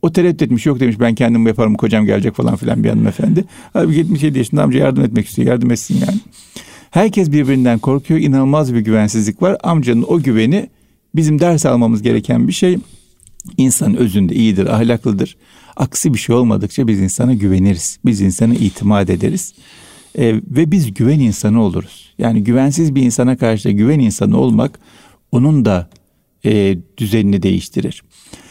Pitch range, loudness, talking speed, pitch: 110-145 Hz, -14 LUFS, 160 wpm, 120 Hz